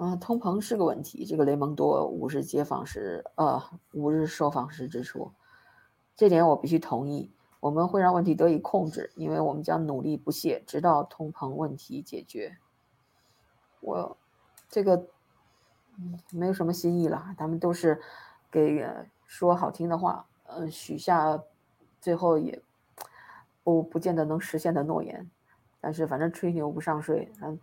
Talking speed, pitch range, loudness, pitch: 230 characters per minute, 150-175 Hz, -28 LUFS, 165 Hz